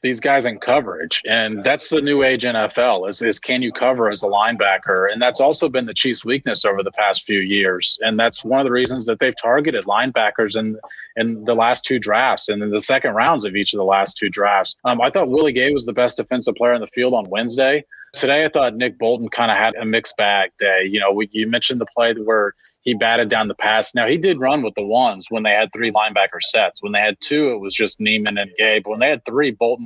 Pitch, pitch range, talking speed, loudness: 115 Hz, 105-125 Hz, 255 wpm, -17 LUFS